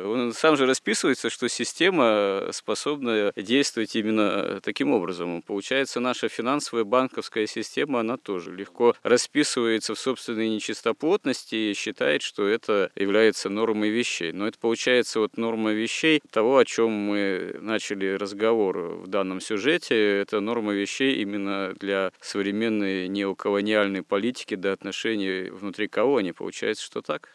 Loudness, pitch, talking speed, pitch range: -25 LUFS, 110 Hz, 135 wpm, 100-120 Hz